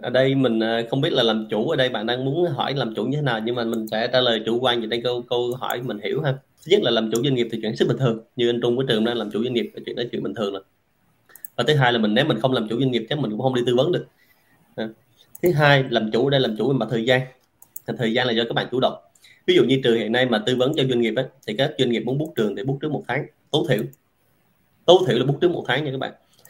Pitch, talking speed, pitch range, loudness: 120 Hz, 320 wpm, 115-135 Hz, -21 LUFS